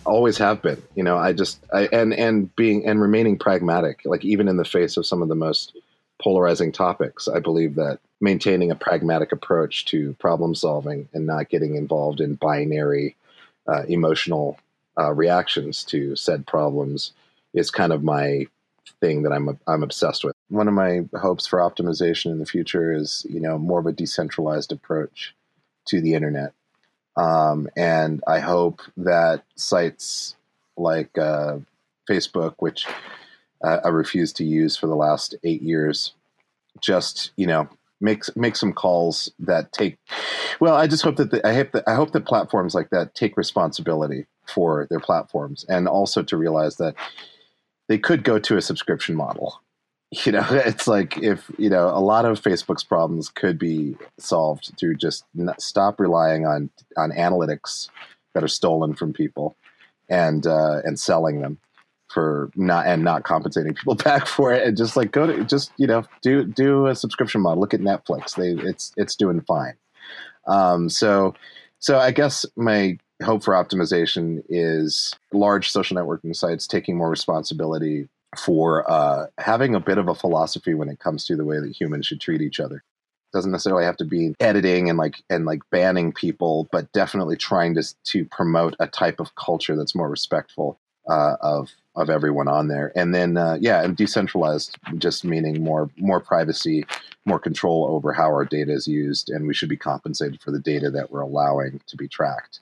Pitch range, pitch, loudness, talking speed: 75-95 Hz, 80 Hz, -21 LUFS, 180 wpm